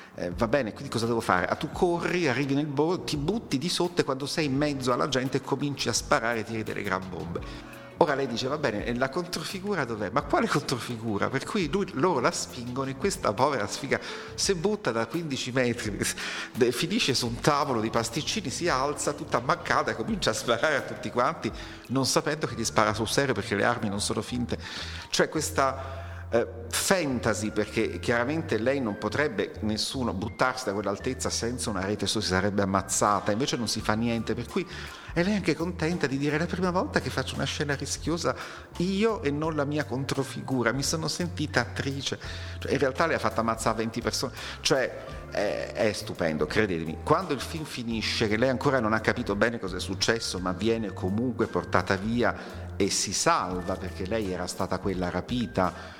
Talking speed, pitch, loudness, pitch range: 195 wpm, 115 Hz, -28 LUFS, 105-140 Hz